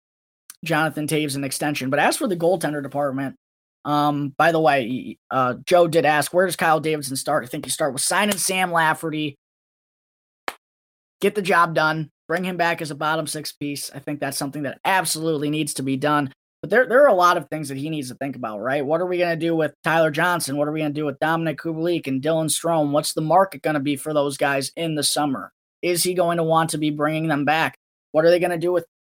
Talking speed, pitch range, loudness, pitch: 245 wpm, 145-165 Hz, -21 LUFS, 155 Hz